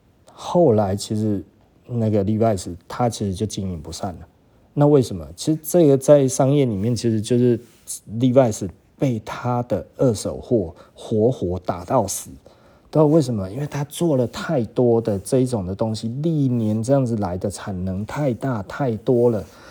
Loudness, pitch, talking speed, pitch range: -21 LUFS, 115 Hz, 255 characters per minute, 100-135 Hz